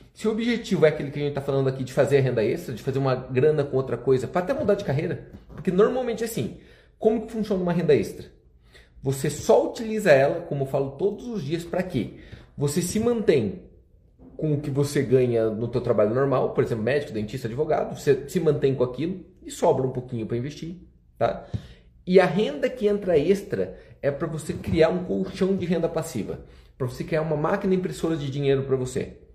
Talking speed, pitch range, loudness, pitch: 210 wpm, 130-190 Hz, -24 LUFS, 155 Hz